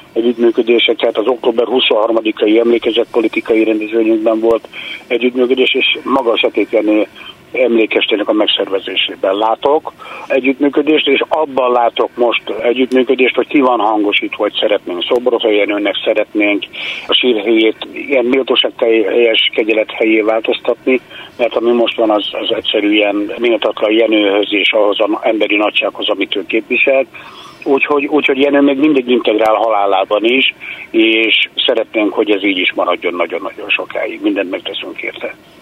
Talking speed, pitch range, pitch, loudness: 130 wpm, 110-130 Hz, 115 Hz, -13 LUFS